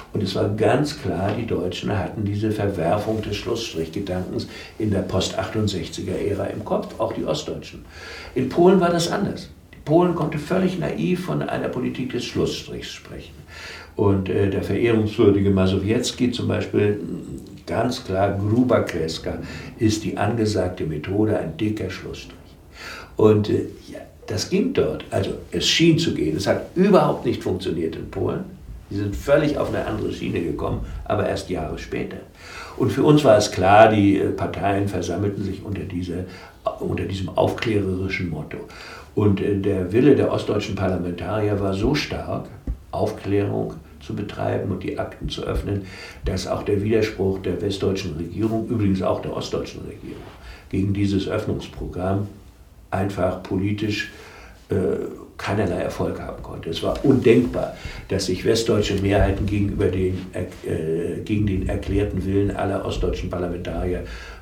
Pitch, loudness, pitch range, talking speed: 100 Hz, -22 LUFS, 90-105 Hz, 145 wpm